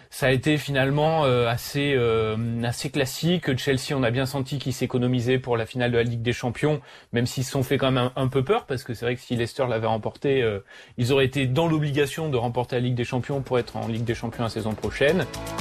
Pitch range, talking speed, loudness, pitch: 120-140 Hz, 235 wpm, -24 LUFS, 125 Hz